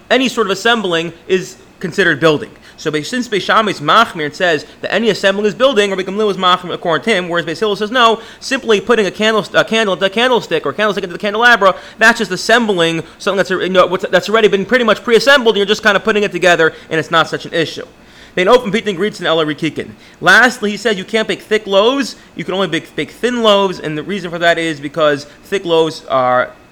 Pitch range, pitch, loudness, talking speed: 165-220 Hz, 195 Hz, -13 LUFS, 220 wpm